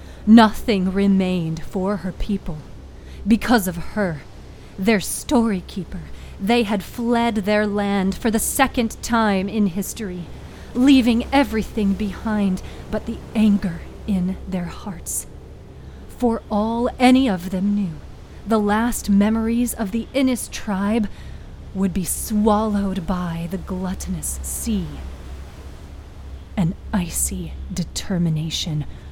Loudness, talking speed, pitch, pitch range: -21 LUFS, 110 wpm, 200 Hz, 175-225 Hz